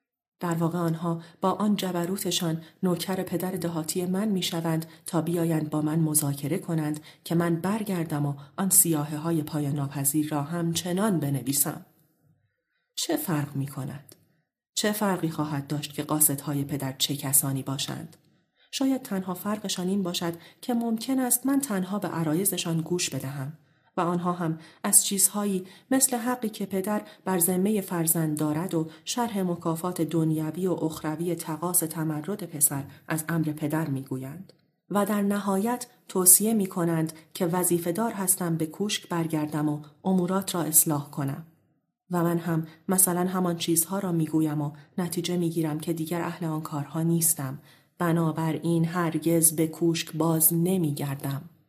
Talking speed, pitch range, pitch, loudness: 150 wpm, 155-185 Hz, 165 Hz, -26 LUFS